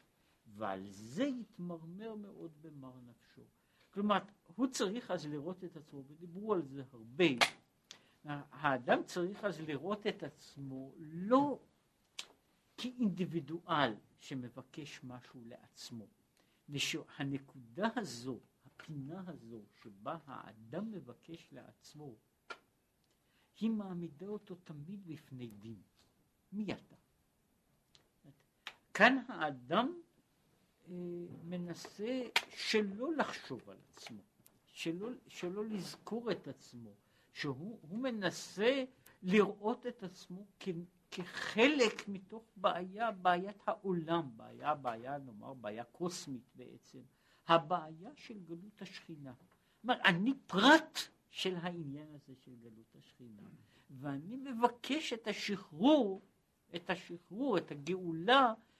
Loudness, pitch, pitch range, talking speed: -37 LUFS, 175 Hz, 140-210 Hz, 100 wpm